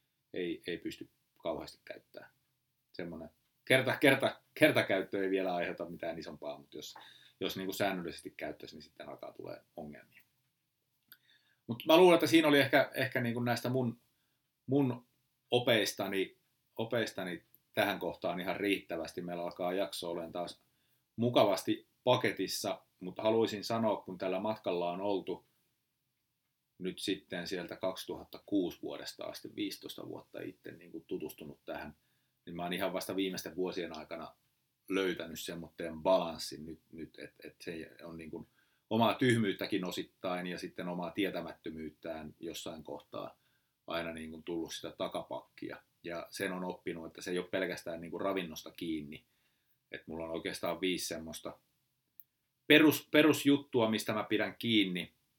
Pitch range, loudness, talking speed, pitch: 90-135 Hz, -34 LUFS, 145 wpm, 105 Hz